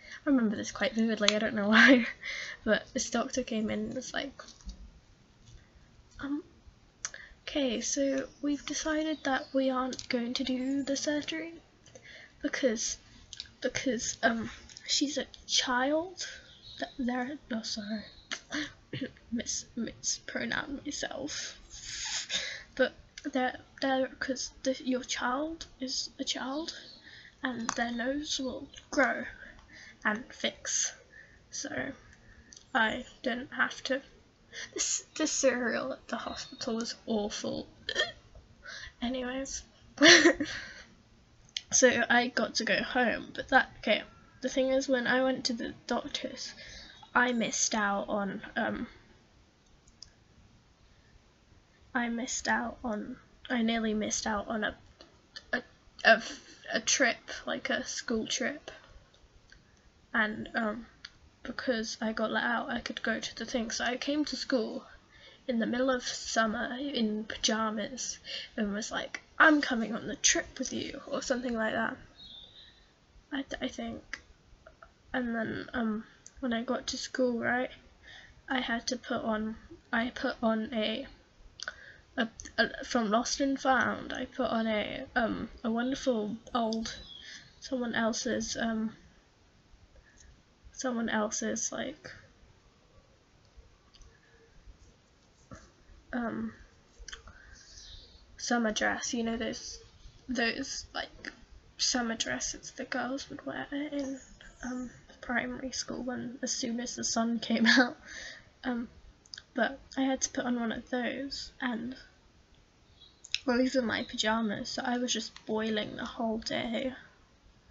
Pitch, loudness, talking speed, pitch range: 250 Hz, -31 LUFS, 125 wpm, 230-270 Hz